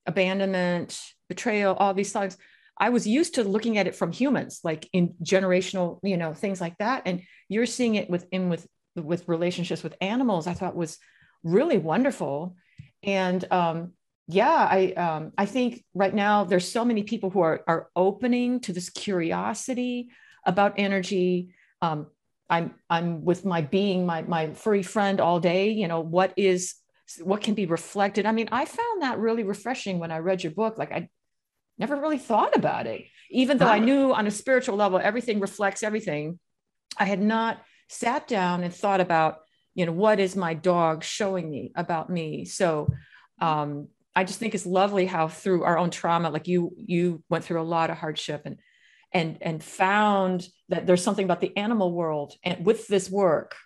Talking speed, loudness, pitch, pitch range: 180 wpm, -25 LUFS, 185 Hz, 170-210 Hz